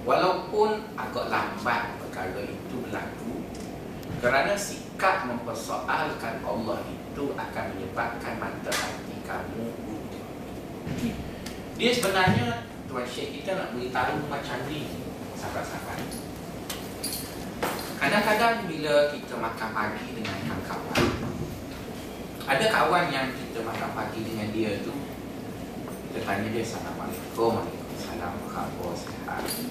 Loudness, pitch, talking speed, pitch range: -29 LUFS, 115 Hz, 105 wpm, 105-145 Hz